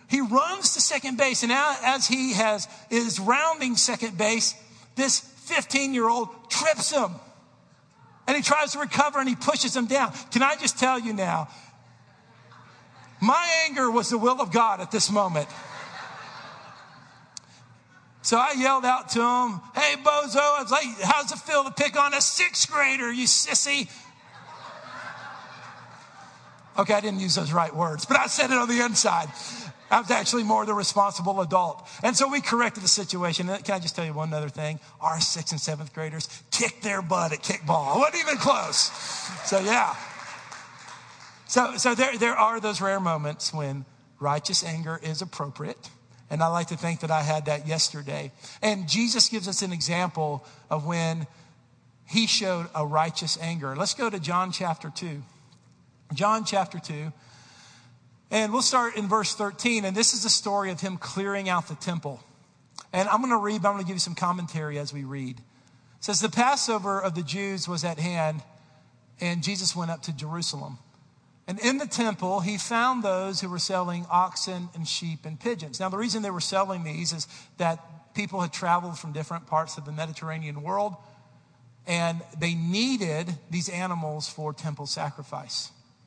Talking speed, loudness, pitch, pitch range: 175 wpm, -25 LUFS, 190 Hz, 160-235 Hz